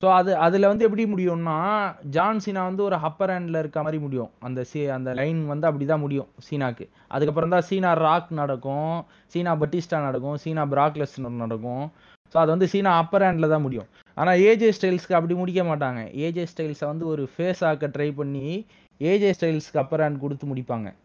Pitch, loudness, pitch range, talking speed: 160 Hz, -24 LUFS, 145-180 Hz, 180 wpm